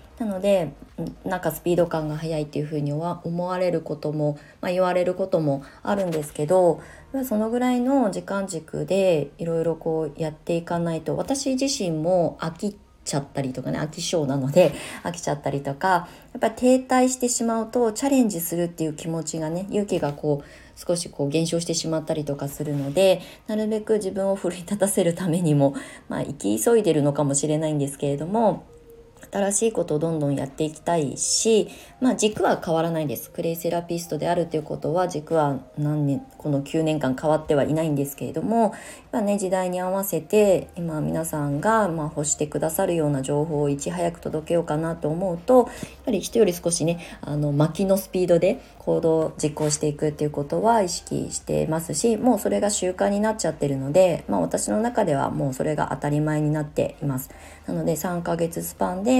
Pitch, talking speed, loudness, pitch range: 165 Hz, 385 characters per minute, -24 LUFS, 150-190 Hz